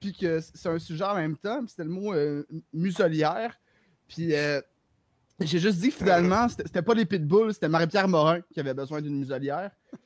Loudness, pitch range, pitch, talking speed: -27 LUFS, 150-200 Hz, 165 Hz, 195 wpm